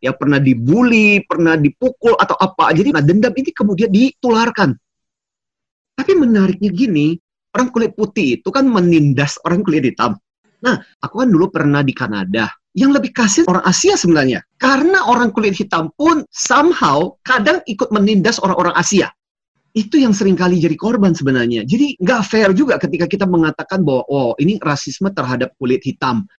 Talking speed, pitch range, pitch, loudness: 155 wpm, 160-245 Hz, 195 Hz, -14 LUFS